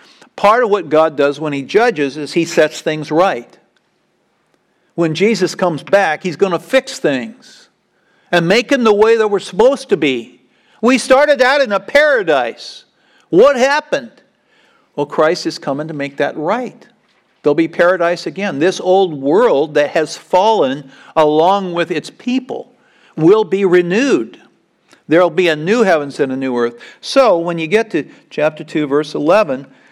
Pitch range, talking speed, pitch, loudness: 155-220 Hz, 165 wpm, 175 Hz, -14 LUFS